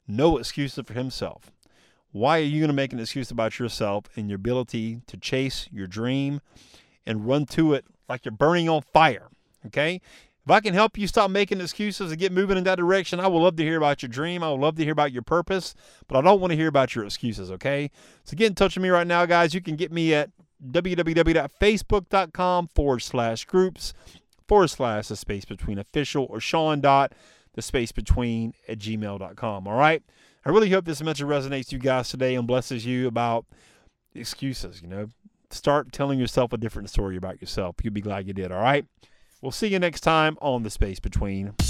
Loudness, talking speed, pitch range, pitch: -24 LUFS, 210 wpm, 115-170 Hz, 140 Hz